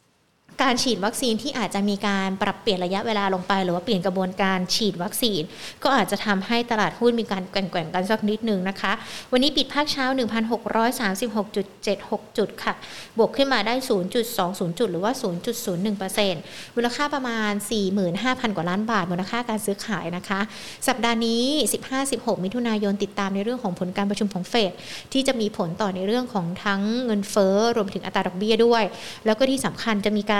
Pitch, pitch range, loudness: 210 Hz, 195-235 Hz, -24 LUFS